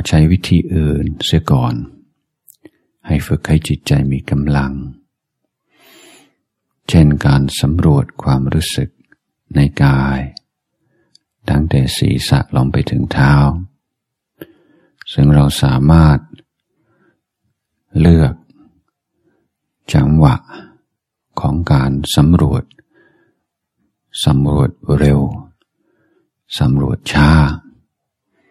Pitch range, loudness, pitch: 70-75 Hz, -14 LUFS, 70 Hz